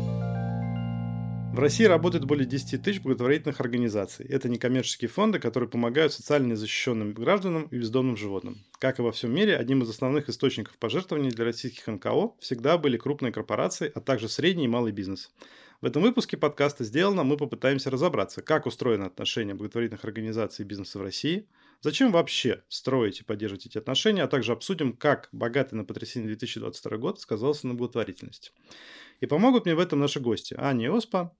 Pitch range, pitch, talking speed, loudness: 110-145 Hz, 125 Hz, 170 wpm, -27 LUFS